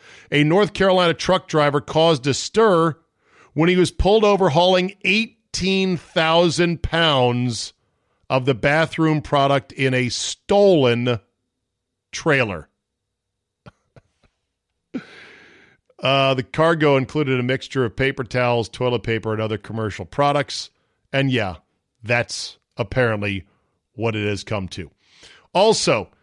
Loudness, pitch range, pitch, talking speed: -19 LUFS, 115-165 Hz, 135 Hz, 110 wpm